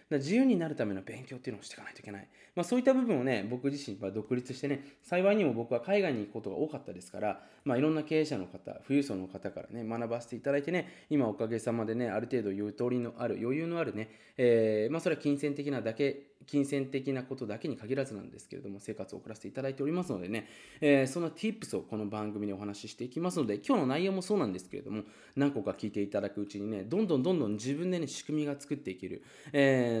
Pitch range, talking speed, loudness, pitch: 110-150 Hz, 510 characters per minute, -33 LUFS, 130 Hz